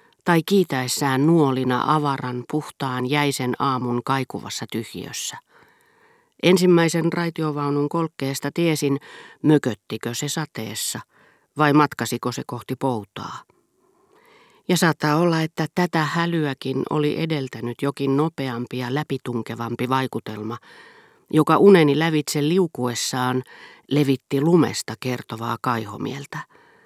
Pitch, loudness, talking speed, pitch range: 140 Hz, -22 LUFS, 95 wpm, 125-160 Hz